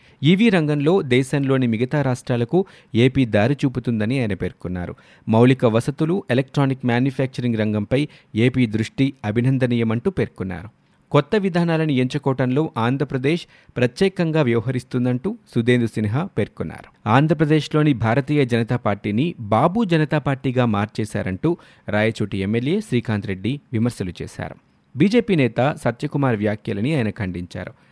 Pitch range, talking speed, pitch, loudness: 115-150 Hz, 105 wpm, 130 Hz, -20 LUFS